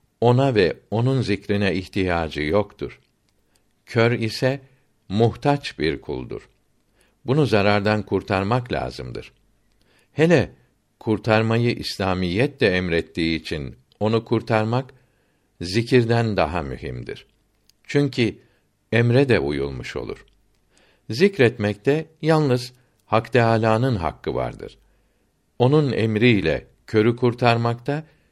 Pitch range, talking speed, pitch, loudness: 95-125 Hz, 85 wpm, 110 Hz, -21 LUFS